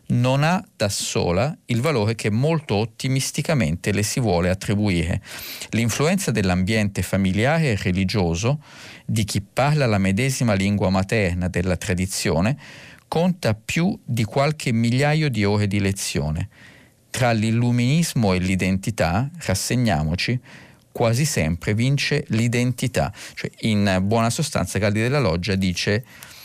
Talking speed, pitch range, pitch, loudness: 120 wpm, 95-130 Hz, 110 Hz, -21 LUFS